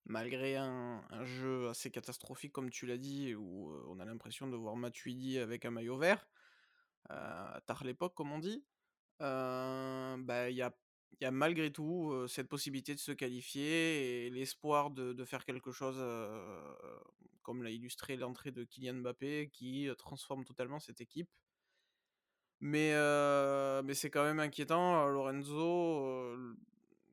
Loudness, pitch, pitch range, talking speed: -39 LUFS, 130 Hz, 125-145 Hz, 155 wpm